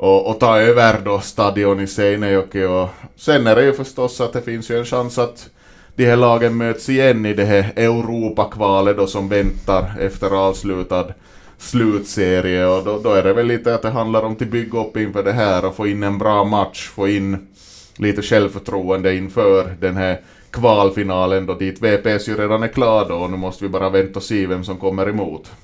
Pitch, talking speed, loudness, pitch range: 100 Hz, 200 wpm, -17 LUFS, 95-115 Hz